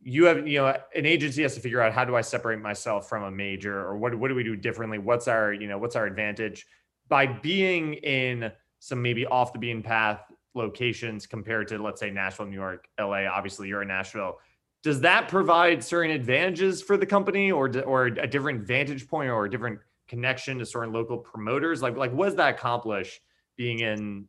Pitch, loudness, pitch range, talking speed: 120 Hz, -26 LUFS, 110-140 Hz, 210 wpm